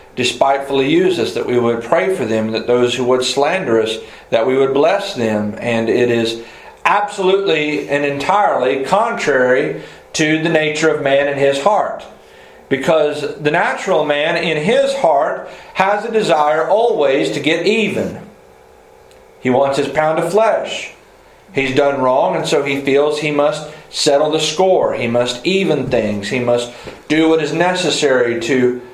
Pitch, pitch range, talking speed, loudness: 145 Hz, 125-170 Hz, 160 wpm, -15 LUFS